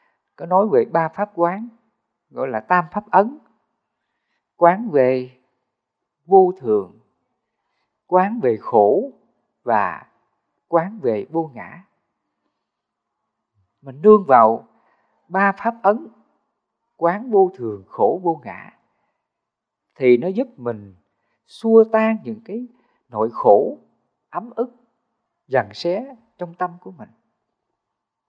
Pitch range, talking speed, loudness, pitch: 165-230 Hz, 115 wpm, -19 LUFS, 190 Hz